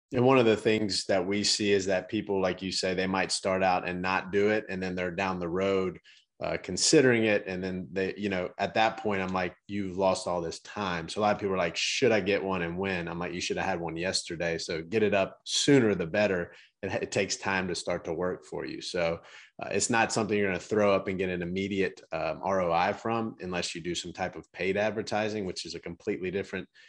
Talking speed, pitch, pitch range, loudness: 255 wpm, 95 Hz, 90-105 Hz, -29 LUFS